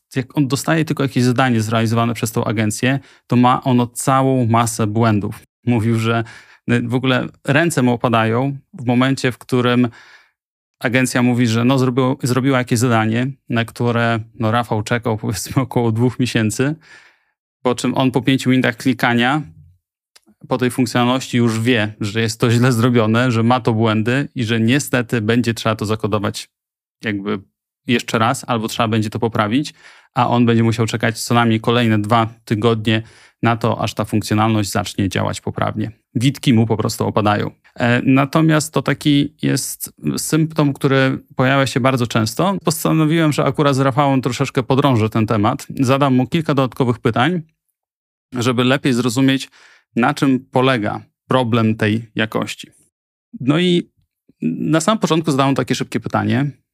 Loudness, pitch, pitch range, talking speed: -17 LUFS, 125 Hz, 115-135 Hz, 155 wpm